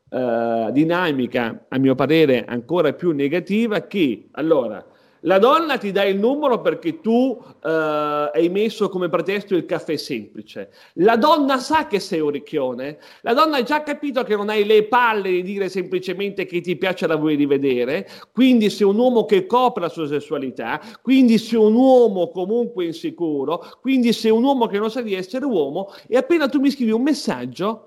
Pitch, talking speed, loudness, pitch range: 200 Hz, 180 wpm, -19 LUFS, 160-245 Hz